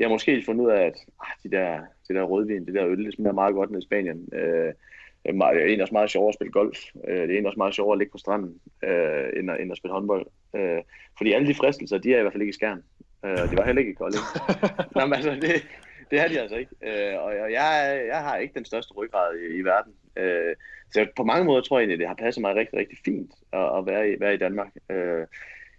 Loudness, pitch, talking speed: -25 LUFS, 115 Hz, 245 wpm